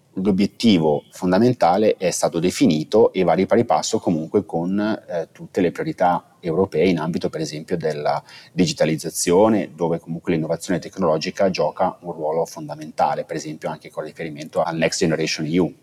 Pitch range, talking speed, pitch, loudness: 80-105 Hz, 150 wpm, 85 Hz, -21 LUFS